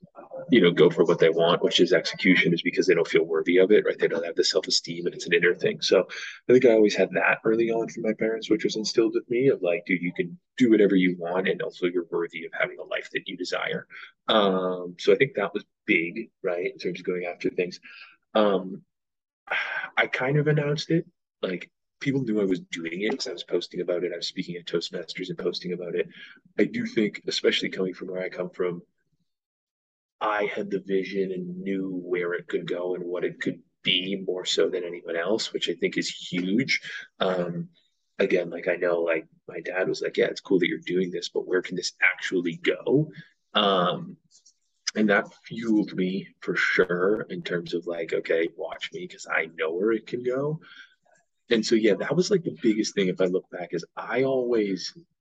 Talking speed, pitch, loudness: 220 wpm, 125 Hz, -25 LUFS